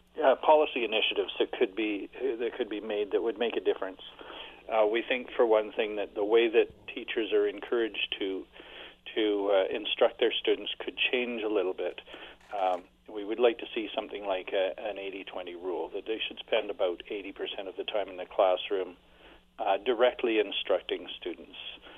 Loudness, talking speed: -30 LUFS, 185 wpm